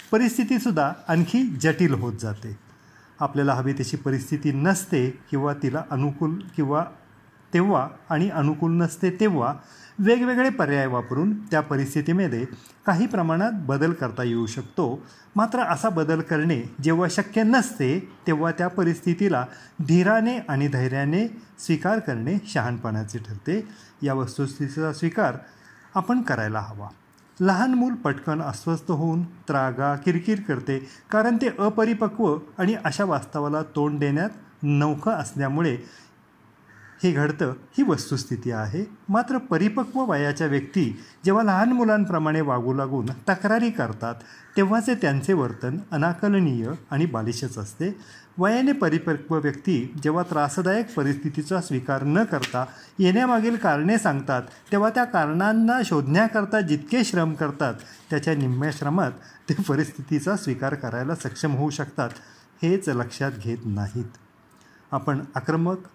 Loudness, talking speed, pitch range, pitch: -24 LUFS, 120 wpm, 135-195 Hz, 155 Hz